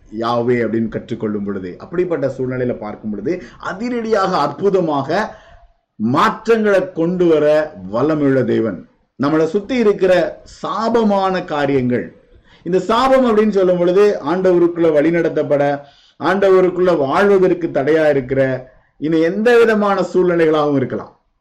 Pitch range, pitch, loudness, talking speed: 135-190 Hz, 160 Hz, -16 LUFS, 105 wpm